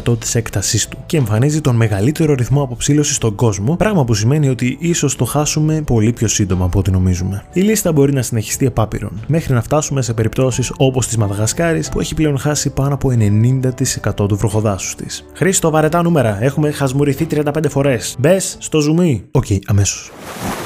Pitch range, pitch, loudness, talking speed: 110-150 Hz, 130 Hz, -15 LUFS, 175 wpm